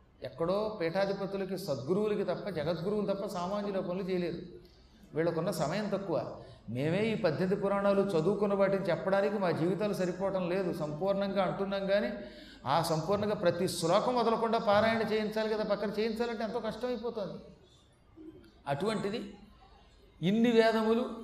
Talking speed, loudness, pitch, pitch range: 115 wpm, -32 LUFS, 200 Hz, 180-215 Hz